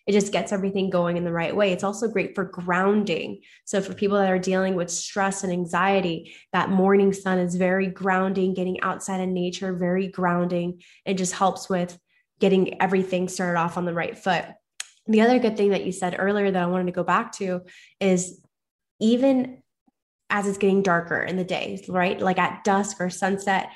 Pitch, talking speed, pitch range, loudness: 185 Hz, 195 wpm, 180-195 Hz, -24 LUFS